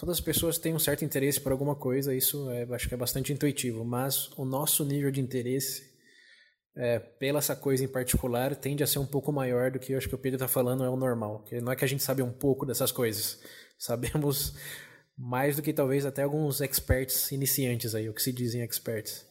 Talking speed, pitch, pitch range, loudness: 225 wpm, 135 Hz, 125-145 Hz, -29 LUFS